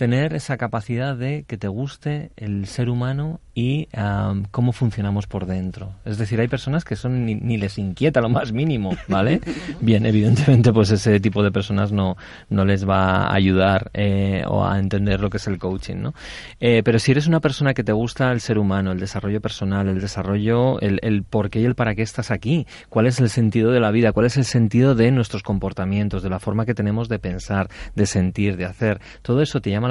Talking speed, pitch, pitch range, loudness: 220 wpm, 110 Hz, 100-125 Hz, -20 LUFS